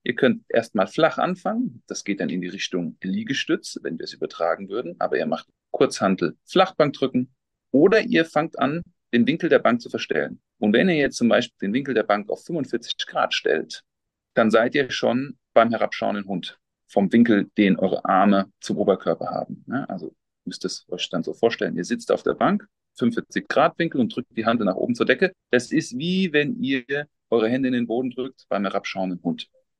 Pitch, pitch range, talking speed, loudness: 135 Hz, 115-185 Hz, 195 wpm, -23 LUFS